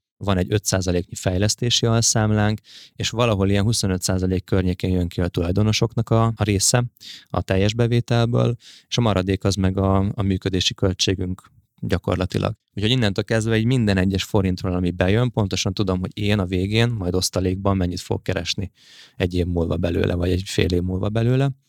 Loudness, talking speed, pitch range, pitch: -21 LUFS, 165 wpm, 95-115 Hz, 100 Hz